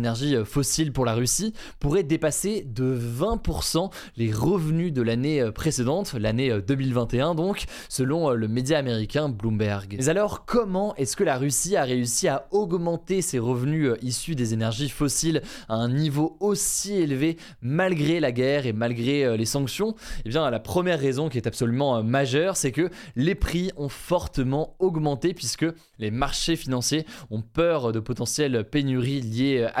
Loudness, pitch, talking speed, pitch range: -25 LUFS, 140 Hz, 155 wpm, 120-165 Hz